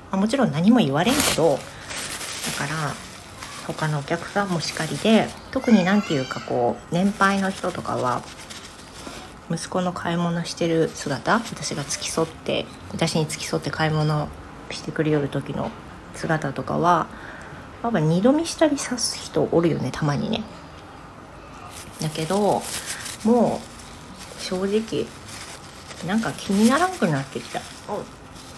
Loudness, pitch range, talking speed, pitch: -23 LUFS, 155-210 Hz, 255 characters per minute, 175 Hz